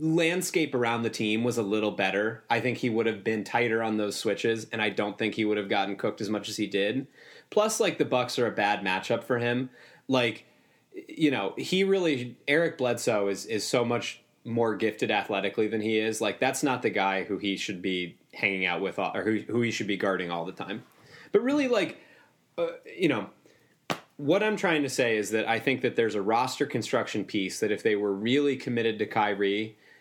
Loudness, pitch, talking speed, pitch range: -28 LUFS, 115 Hz, 220 wpm, 105-135 Hz